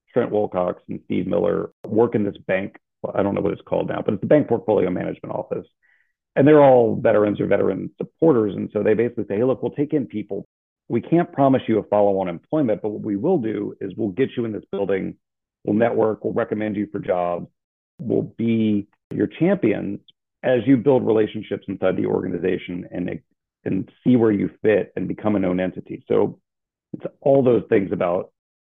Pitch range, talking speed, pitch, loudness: 100-120 Hz, 200 wpm, 105 Hz, -21 LUFS